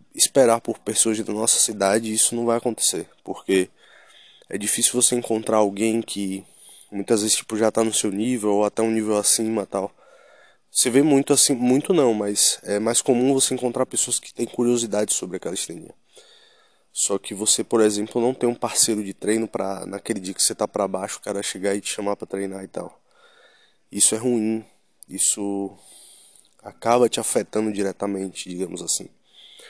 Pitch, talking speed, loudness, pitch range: 110 Hz, 180 wpm, -21 LUFS, 100-120 Hz